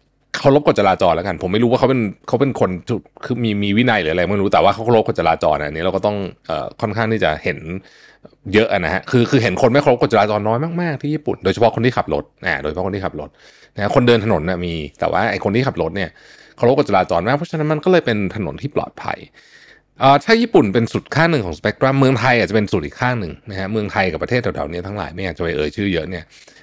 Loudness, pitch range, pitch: -17 LUFS, 95-130 Hz, 110 Hz